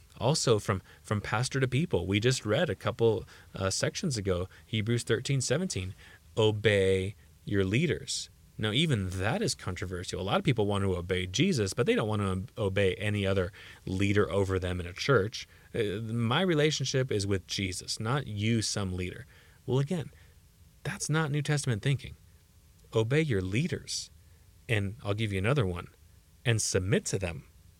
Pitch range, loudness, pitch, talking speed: 90-125 Hz, -30 LUFS, 105 Hz, 165 wpm